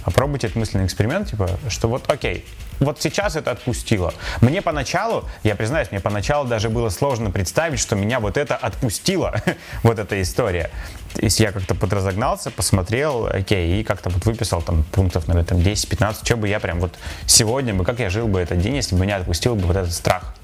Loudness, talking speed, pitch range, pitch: -20 LUFS, 195 wpm, 95-115 Hz, 105 Hz